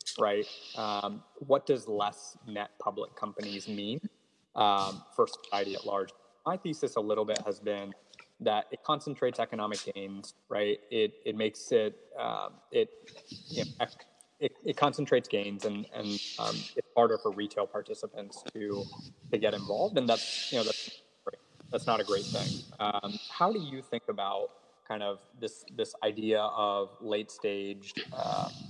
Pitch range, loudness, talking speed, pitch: 100-130 Hz, -33 LUFS, 160 wpm, 105 Hz